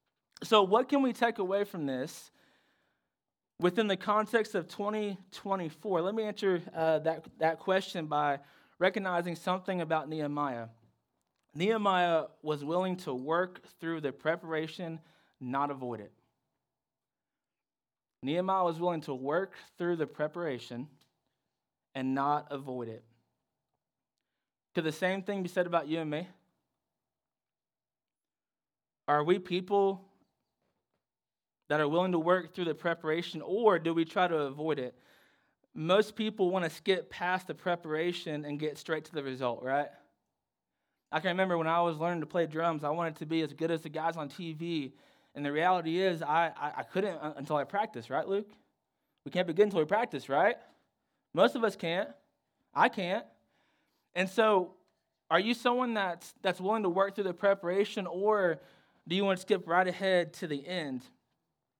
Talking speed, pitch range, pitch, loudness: 160 wpm, 150-190 Hz, 170 Hz, -32 LUFS